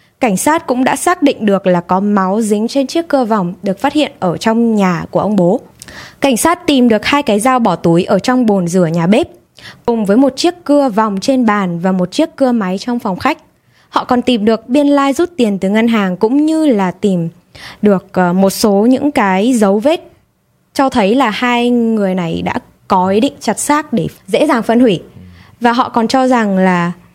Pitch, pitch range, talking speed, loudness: 225 Hz, 190-270 Hz, 220 wpm, -13 LUFS